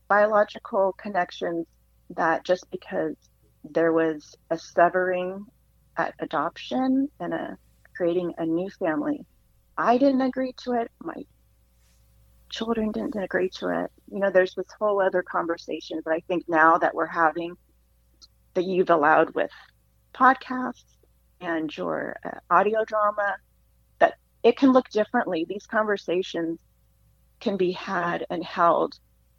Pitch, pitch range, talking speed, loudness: 185 Hz, 165-215 Hz, 130 wpm, -25 LUFS